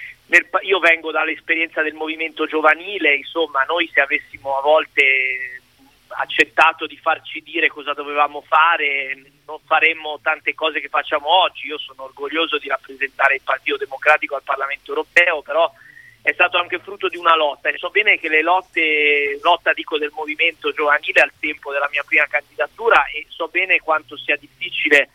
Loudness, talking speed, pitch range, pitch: -17 LUFS, 165 wpm, 145-165 Hz, 155 Hz